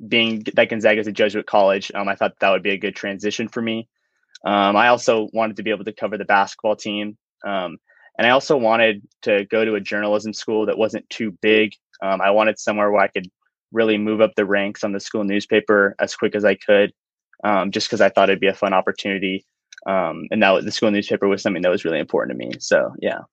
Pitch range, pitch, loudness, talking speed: 100-110 Hz, 105 Hz, -19 LUFS, 240 wpm